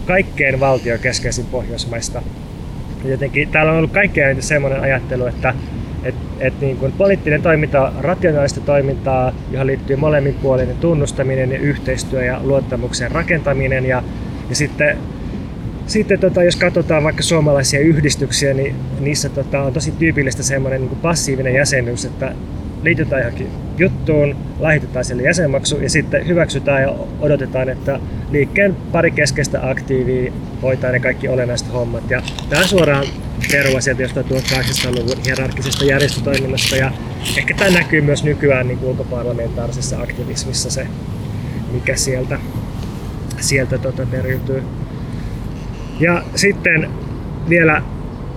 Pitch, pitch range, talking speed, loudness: 135 Hz, 130-145 Hz, 125 wpm, -17 LUFS